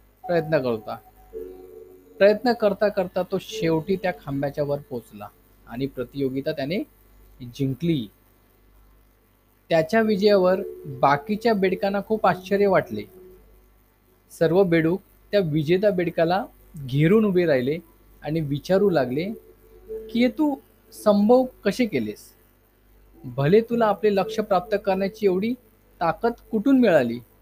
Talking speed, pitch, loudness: 105 wpm, 170 Hz, -22 LUFS